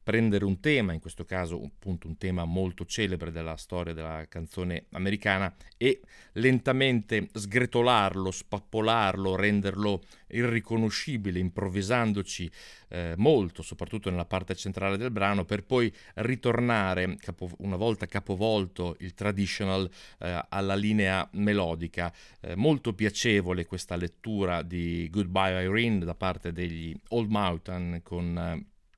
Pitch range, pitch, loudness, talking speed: 90-105 Hz, 95 Hz, -29 LUFS, 120 wpm